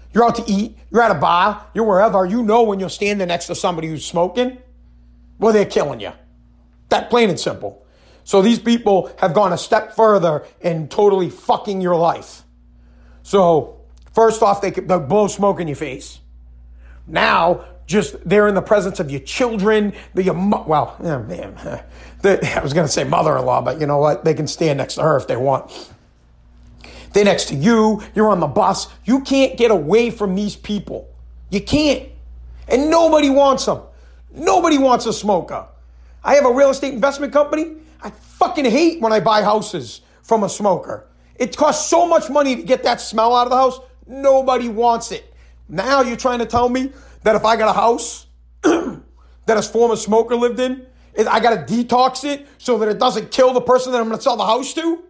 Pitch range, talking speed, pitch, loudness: 165-245 Hz, 195 wpm, 215 Hz, -17 LUFS